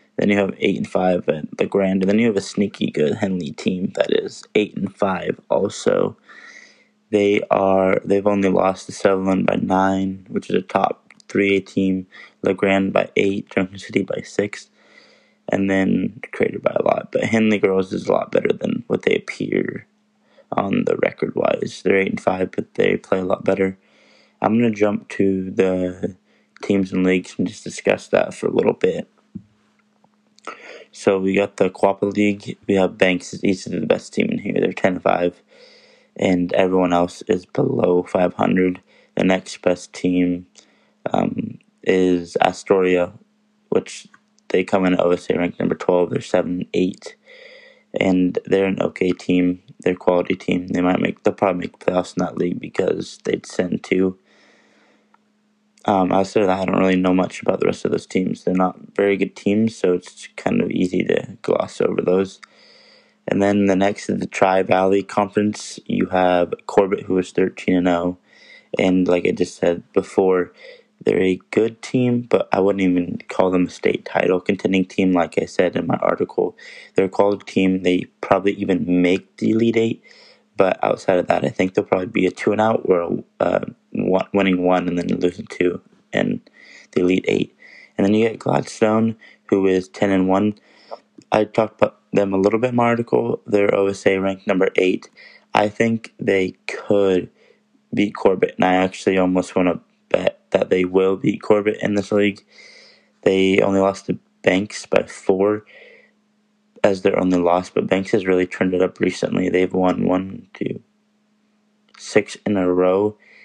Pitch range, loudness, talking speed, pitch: 90-105 Hz, -20 LUFS, 180 wpm, 95 Hz